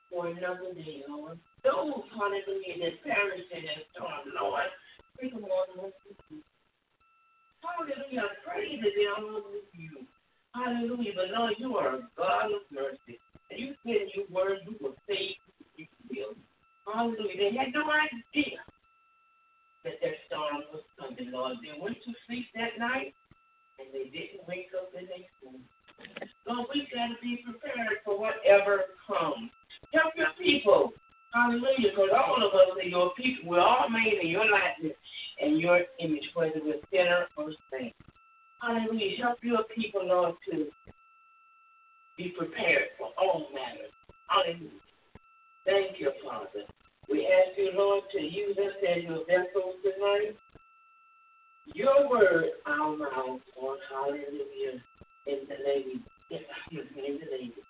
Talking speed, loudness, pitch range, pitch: 135 wpm, -30 LUFS, 175-275 Hz, 205 Hz